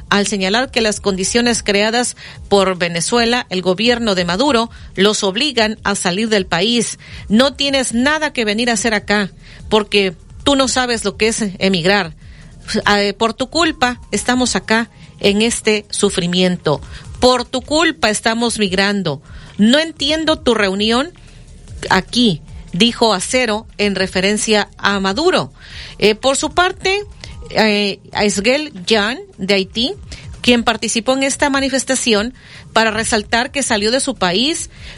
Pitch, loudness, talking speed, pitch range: 220 Hz, -15 LUFS, 135 wpm, 200-250 Hz